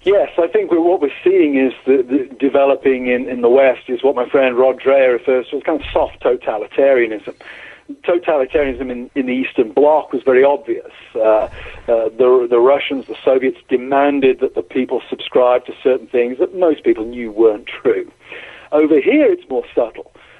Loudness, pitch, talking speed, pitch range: -15 LUFS, 135 Hz, 185 wpm, 125-195 Hz